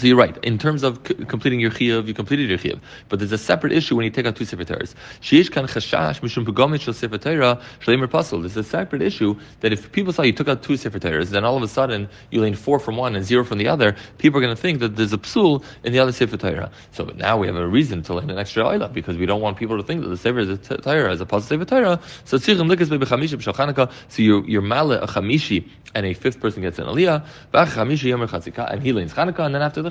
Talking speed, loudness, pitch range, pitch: 235 wpm, -20 LUFS, 105-140 Hz, 120 Hz